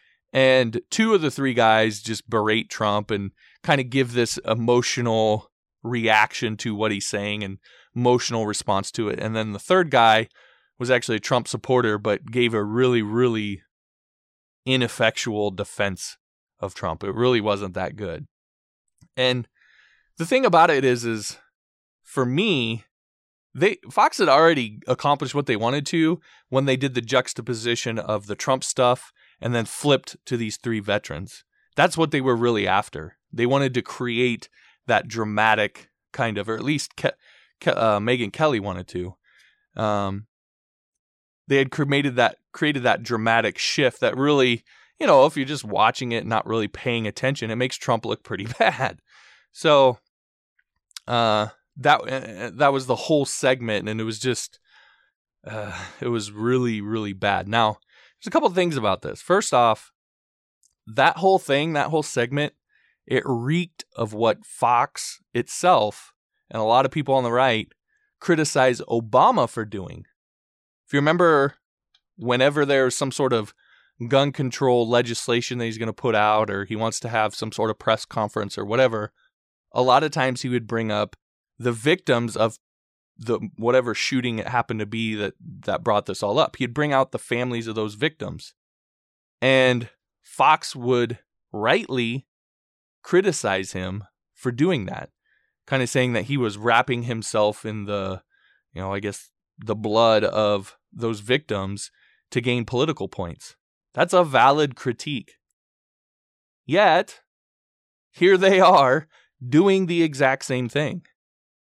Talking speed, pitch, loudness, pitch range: 160 wpm, 120 Hz, -22 LUFS, 105-135 Hz